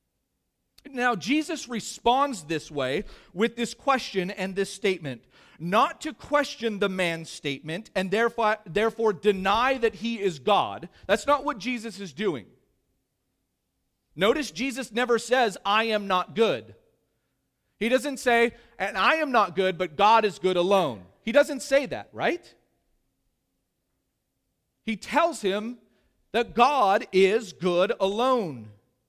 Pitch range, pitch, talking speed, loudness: 185-245 Hz, 215 Hz, 135 wpm, -25 LUFS